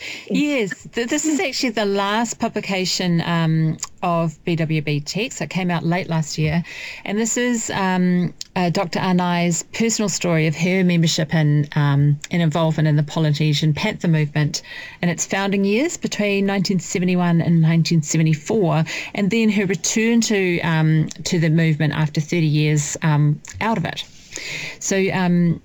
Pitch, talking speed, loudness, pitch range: 175 Hz, 155 wpm, -19 LUFS, 160-200 Hz